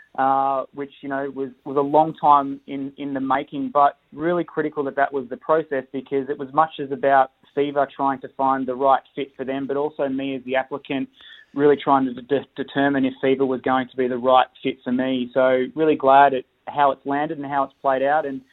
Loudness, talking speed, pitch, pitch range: -21 LUFS, 230 wpm, 135 Hz, 135-140 Hz